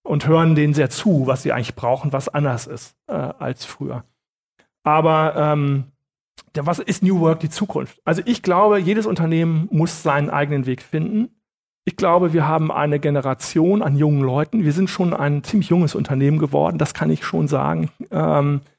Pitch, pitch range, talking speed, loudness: 155 Hz, 145-175 Hz, 180 wpm, -19 LUFS